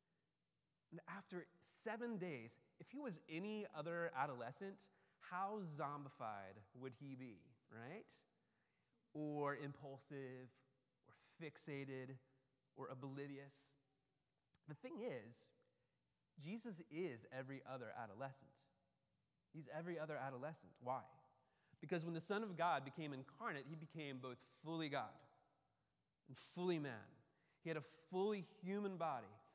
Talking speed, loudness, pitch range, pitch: 115 wpm, -50 LUFS, 130-170 Hz, 145 Hz